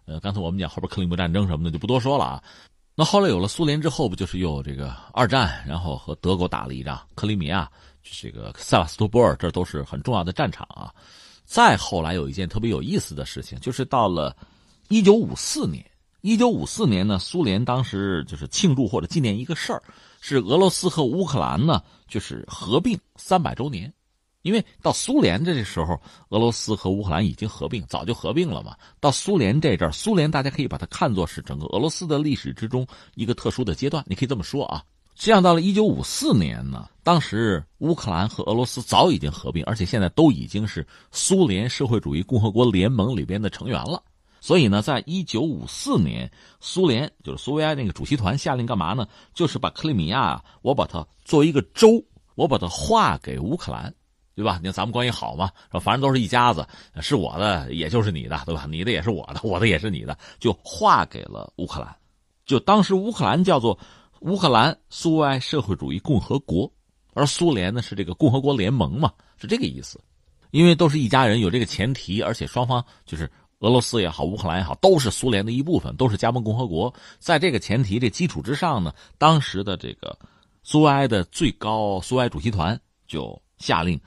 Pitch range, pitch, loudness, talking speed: 90-145 Hz, 115 Hz, -22 LUFS, 320 characters per minute